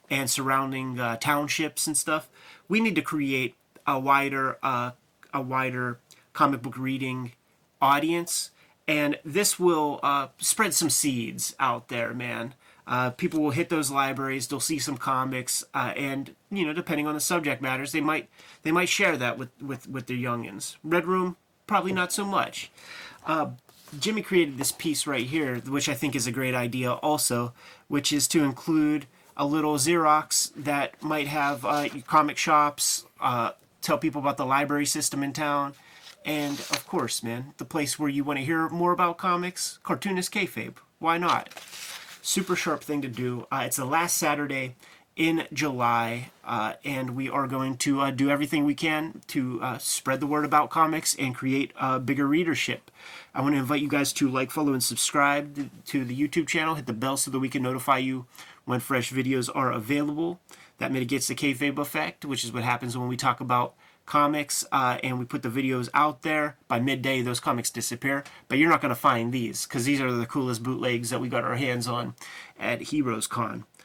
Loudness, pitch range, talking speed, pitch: -26 LUFS, 130-155 Hz, 190 wpm, 140 Hz